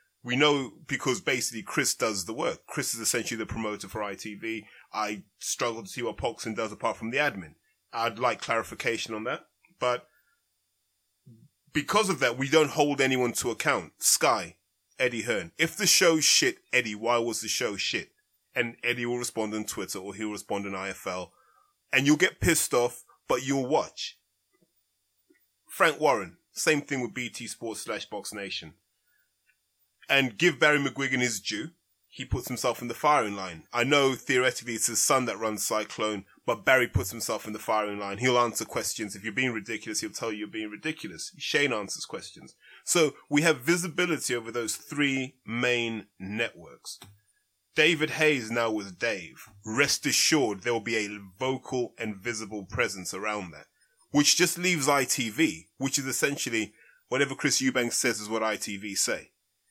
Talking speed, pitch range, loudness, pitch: 170 wpm, 110-140 Hz, -27 LUFS, 120 Hz